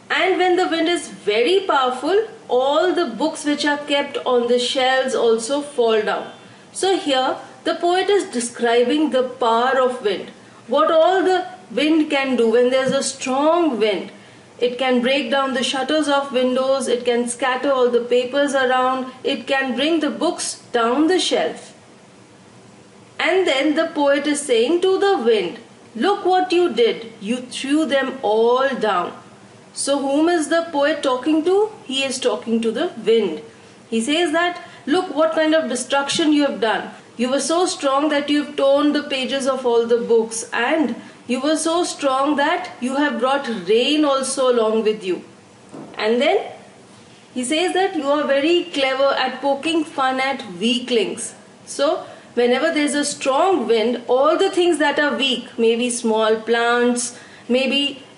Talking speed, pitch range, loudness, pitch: 170 wpm, 250-325 Hz, -19 LUFS, 275 Hz